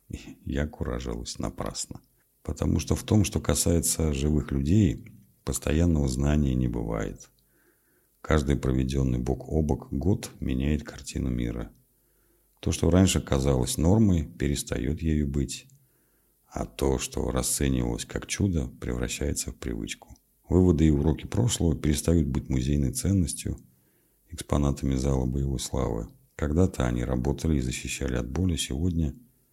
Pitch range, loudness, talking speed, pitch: 65-80 Hz, -27 LUFS, 125 wpm, 70 Hz